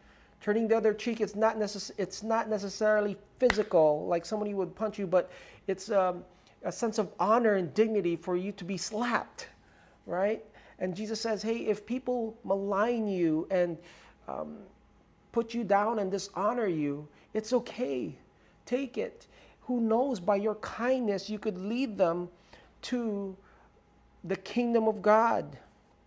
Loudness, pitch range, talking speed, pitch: -30 LUFS, 190-225 Hz, 150 wpm, 210 Hz